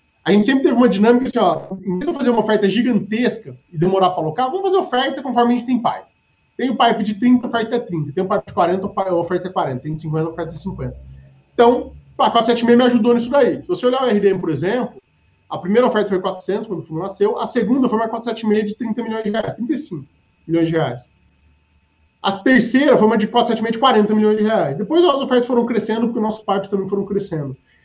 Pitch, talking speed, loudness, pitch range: 215 Hz, 240 wpm, -18 LUFS, 180-240 Hz